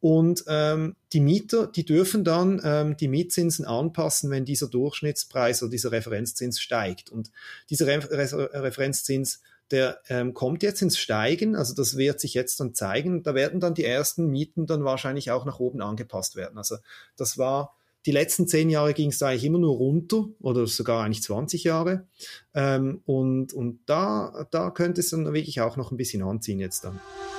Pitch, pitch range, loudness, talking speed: 140 Hz, 125-165 Hz, -25 LUFS, 185 wpm